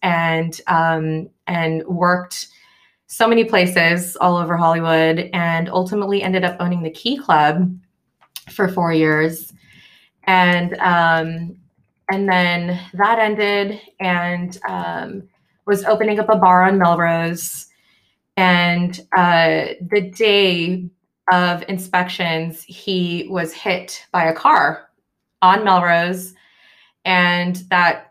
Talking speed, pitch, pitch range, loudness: 110 wpm, 180 Hz, 165-185 Hz, -17 LUFS